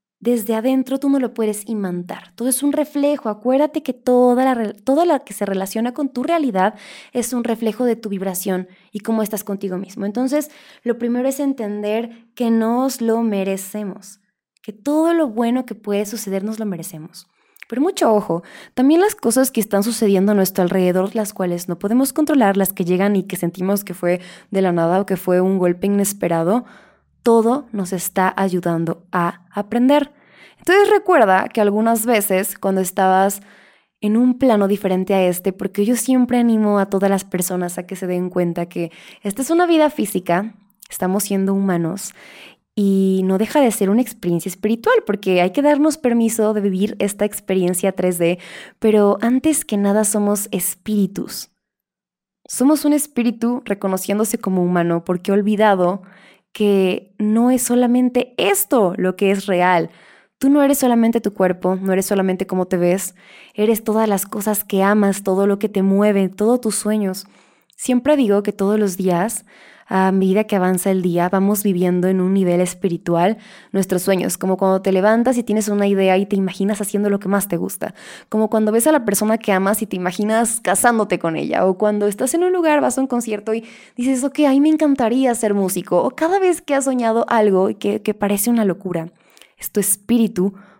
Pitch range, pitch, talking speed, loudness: 190-235 Hz, 205 Hz, 185 wpm, -18 LUFS